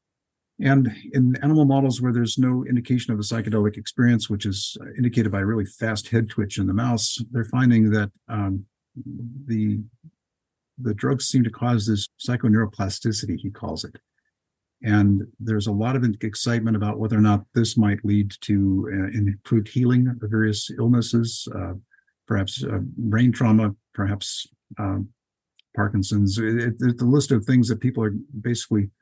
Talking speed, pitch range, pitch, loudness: 160 wpm, 105-120 Hz, 110 Hz, -22 LUFS